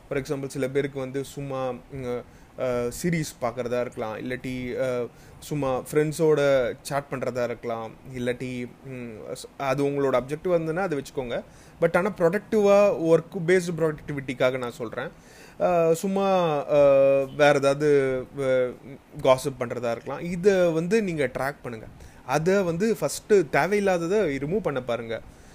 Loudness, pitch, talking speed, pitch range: -25 LUFS, 140 Hz, 115 wpm, 130-165 Hz